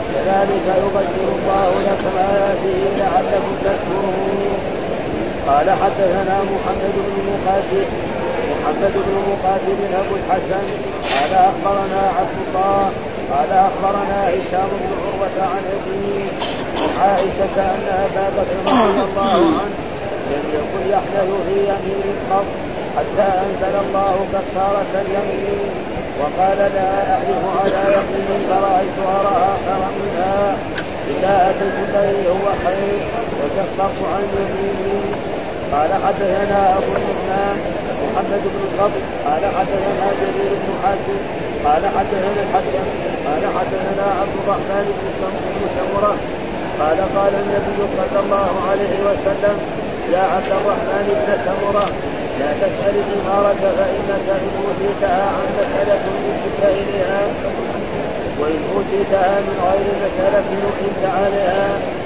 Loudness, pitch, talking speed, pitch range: -18 LUFS, 195 Hz, 105 wpm, 190-200 Hz